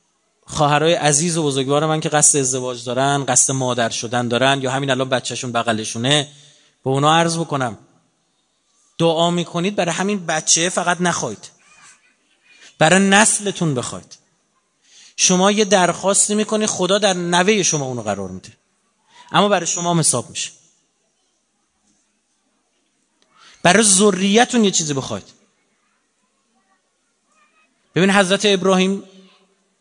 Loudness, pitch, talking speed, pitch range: -16 LUFS, 170 Hz, 115 wpm, 135-195 Hz